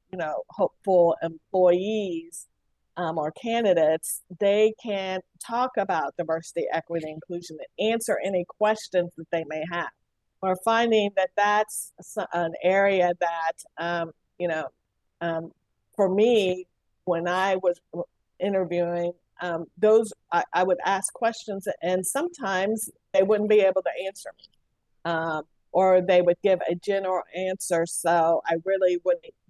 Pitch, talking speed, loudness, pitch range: 180 Hz, 135 wpm, -25 LUFS, 170-200 Hz